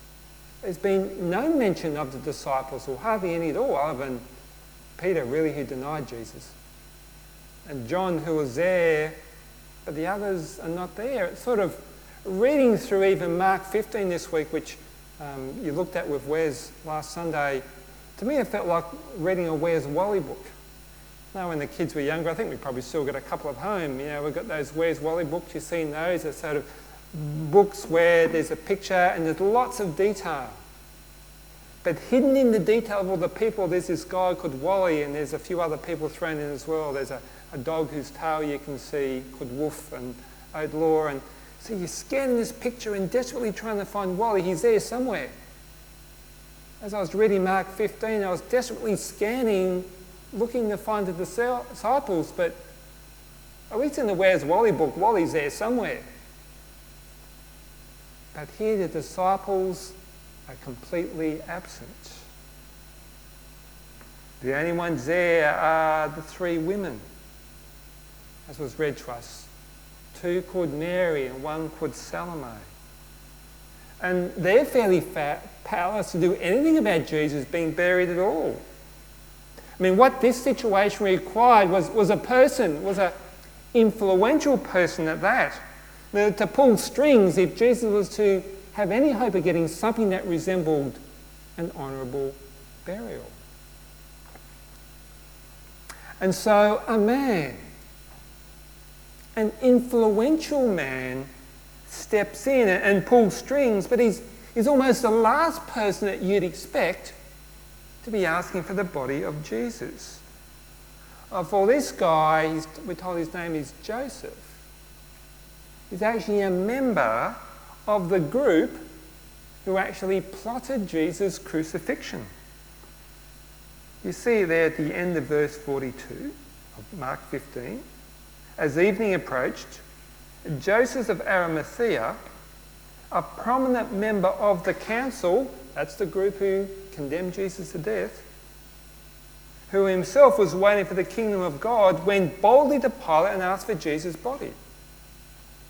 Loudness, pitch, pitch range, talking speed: -25 LUFS, 180 Hz, 155-210 Hz, 145 wpm